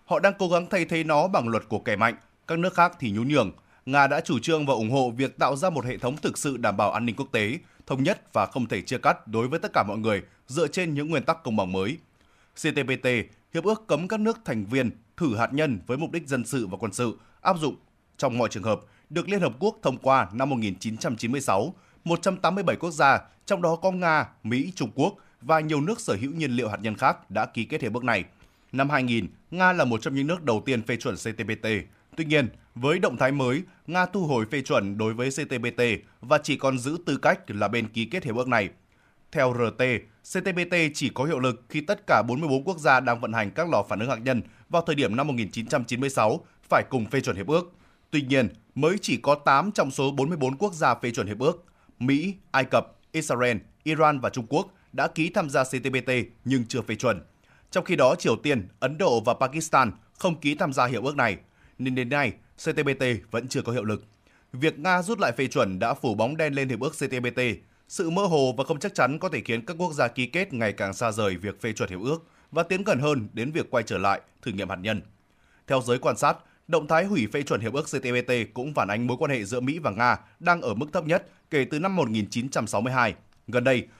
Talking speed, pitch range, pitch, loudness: 240 wpm, 115-160 Hz, 135 Hz, -26 LUFS